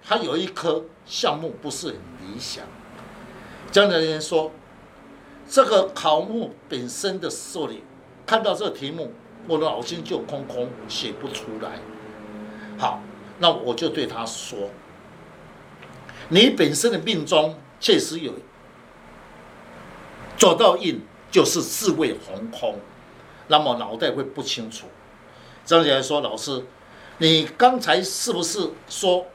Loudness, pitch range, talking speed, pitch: -22 LUFS, 125-180 Hz, 175 characters per minute, 155 Hz